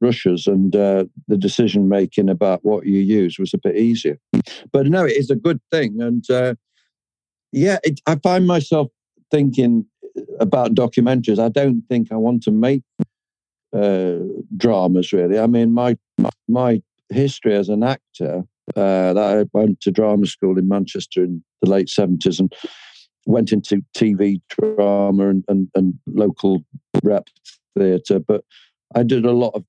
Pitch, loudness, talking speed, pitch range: 105 Hz, -18 LUFS, 160 wpm, 95-125 Hz